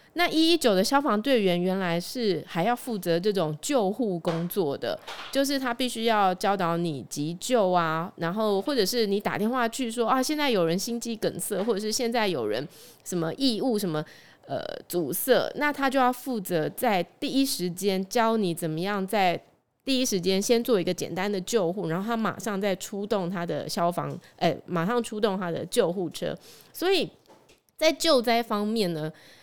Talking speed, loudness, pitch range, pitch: 265 characters per minute, -26 LUFS, 175-240 Hz, 205 Hz